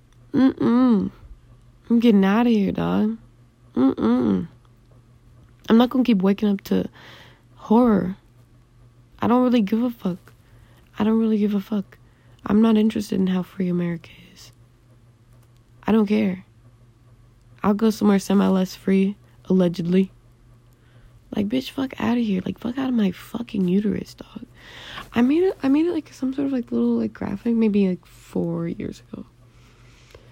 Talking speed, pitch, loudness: 155 wpm, 190 Hz, -21 LUFS